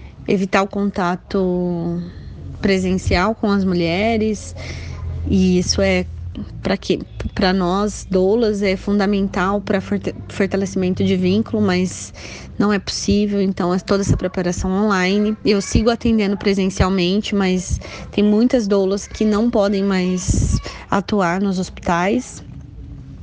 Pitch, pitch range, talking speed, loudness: 195 Hz, 180-205 Hz, 120 wpm, -18 LUFS